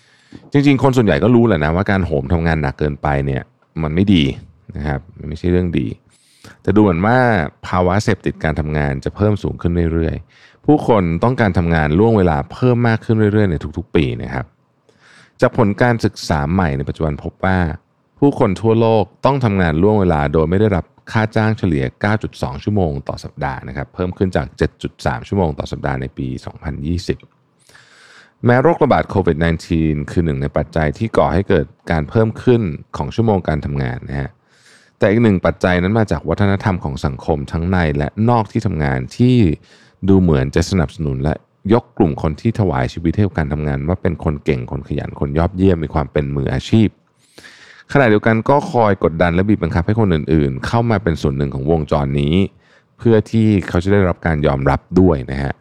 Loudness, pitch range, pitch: -17 LUFS, 75-110 Hz, 90 Hz